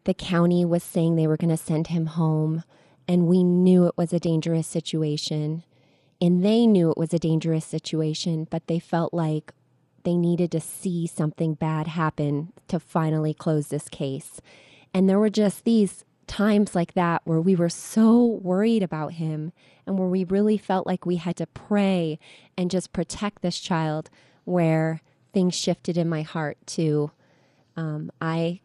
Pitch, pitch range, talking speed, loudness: 165 Hz, 155-180 Hz, 170 wpm, -24 LUFS